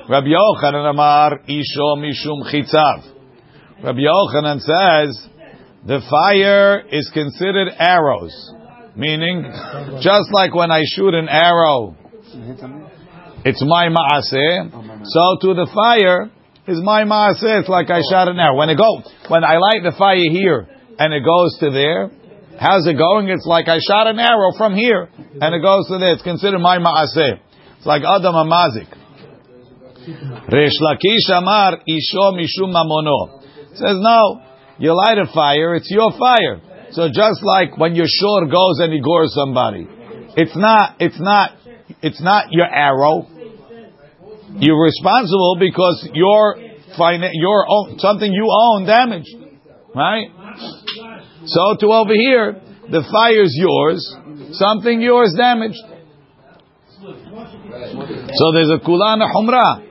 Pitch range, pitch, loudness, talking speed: 150-205 Hz, 175 Hz, -14 LUFS, 130 wpm